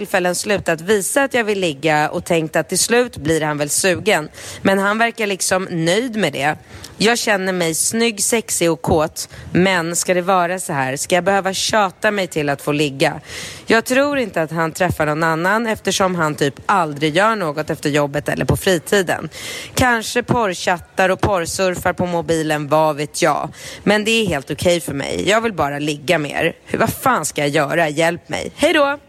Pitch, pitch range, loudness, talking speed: 180 Hz, 155-205 Hz, -17 LUFS, 195 wpm